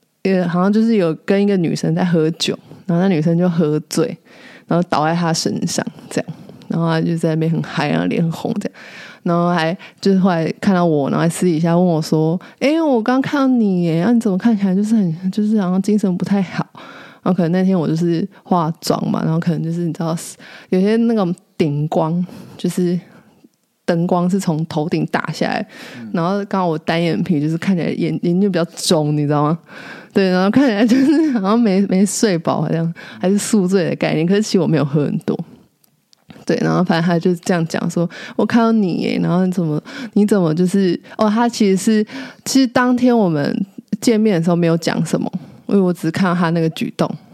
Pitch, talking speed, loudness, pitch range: 185 Hz, 315 characters per minute, -17 LUFS, 170-215 Hz